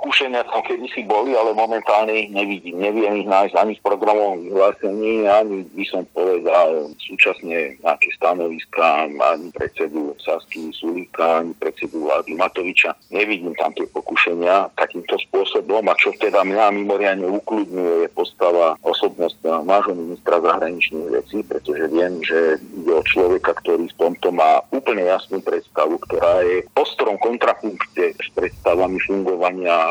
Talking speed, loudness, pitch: 140 wpm, -19 LUFS, 115 Hz